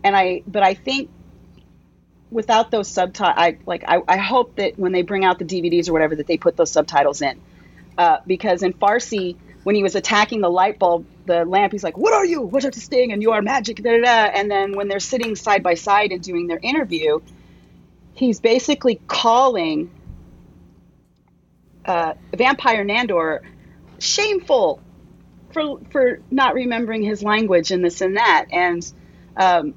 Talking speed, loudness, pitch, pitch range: 175 wpm, -18 LUFS, 205 Hz, 180-245 Hz